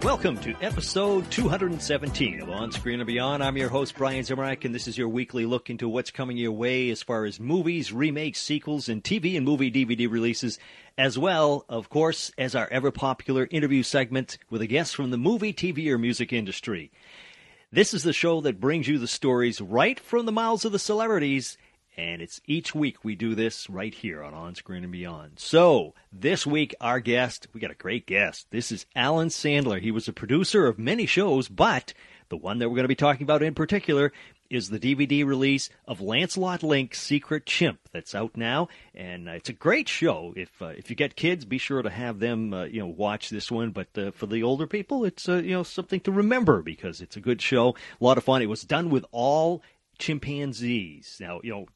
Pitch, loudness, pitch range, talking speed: 130 Hz, -26 LUFS, 115-155 Hz, 215 wpm